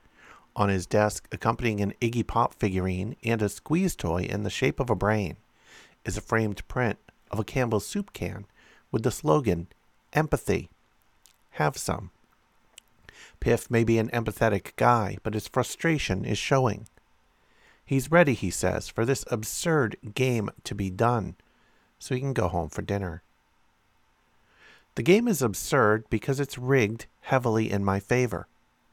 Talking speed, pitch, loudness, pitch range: 150 wpm, 110 Hz, -27 LUFS, 100-125 Hz